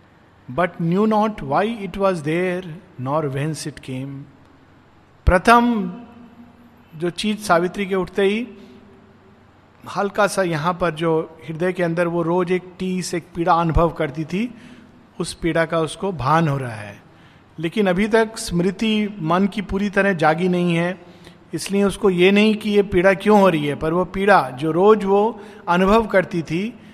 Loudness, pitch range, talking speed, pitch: -19 LUFS, 165-205 Hz, 165 wpm, 180 Hz